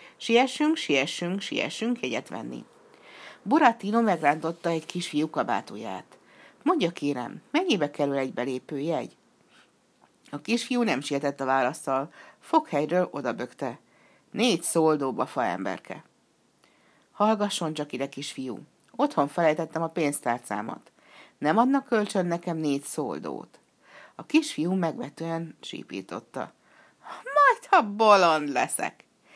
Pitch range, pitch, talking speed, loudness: 140-220 Hz, 165 Hz, 105 wpm, -26 LUFS